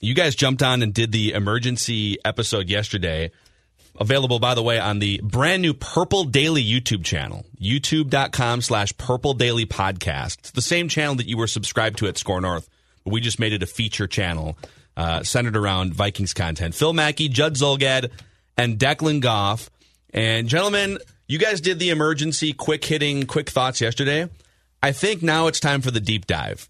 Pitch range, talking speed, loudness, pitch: 105-145 Hz, 180 wpm, -21 LUFS, 120 Hz